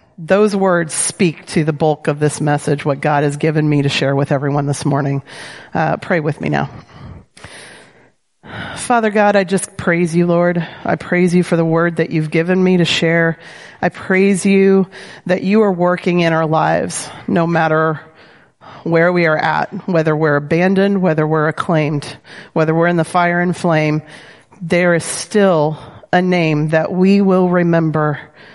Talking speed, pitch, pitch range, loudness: 170 wpm, 165 Hz, 155-185 Hz, -15 LUFS